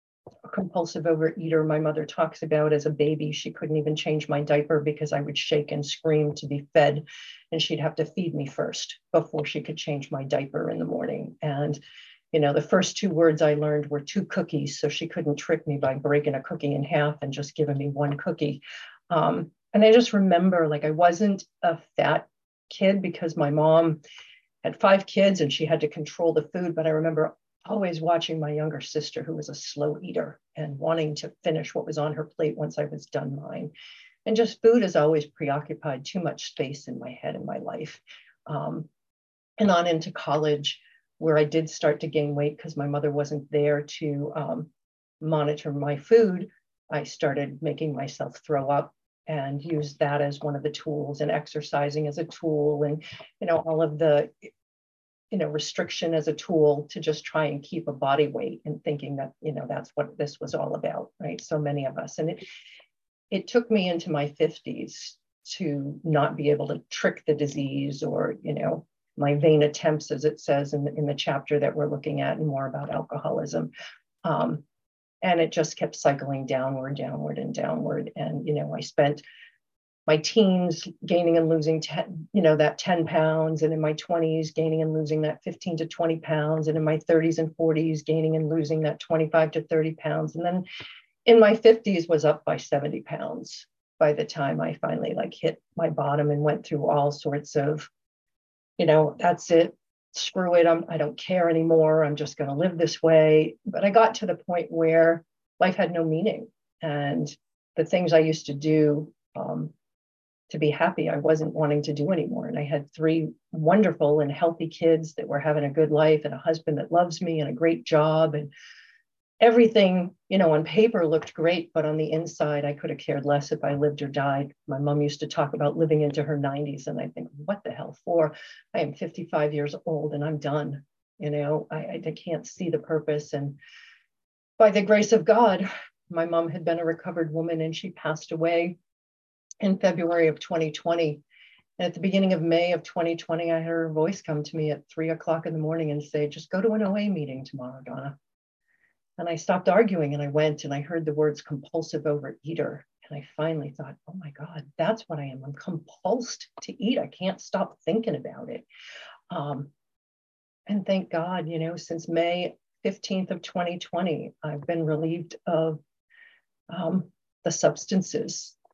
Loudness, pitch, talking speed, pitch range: -26 LUFS, 155 Hz, 200 wpm, 150-165 Hz